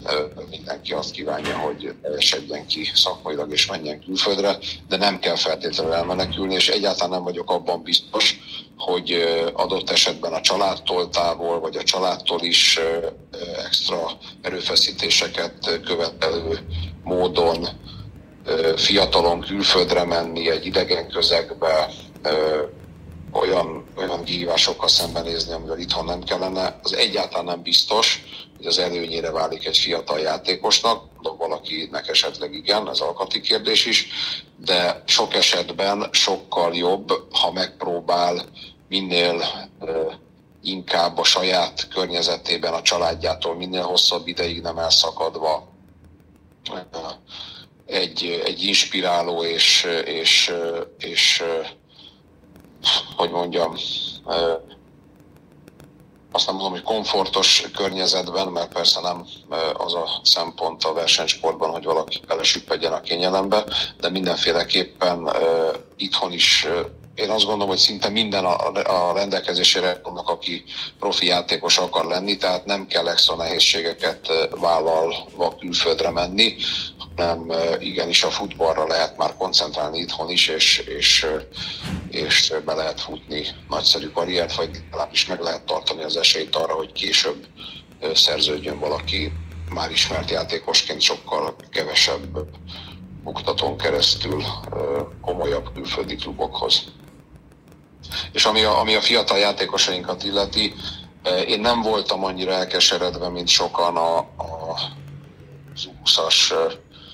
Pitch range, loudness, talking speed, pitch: 85-95 Hz, -20 LUFS, 115 wpm, 90 Hz